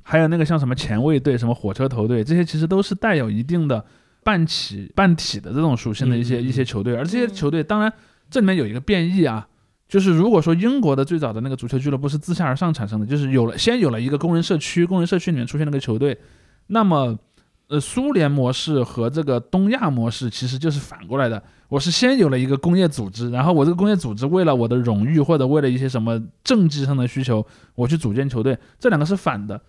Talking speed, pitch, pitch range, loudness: 370 characters per minute, 140 Hz, 120-170 Hz, -20 LUFS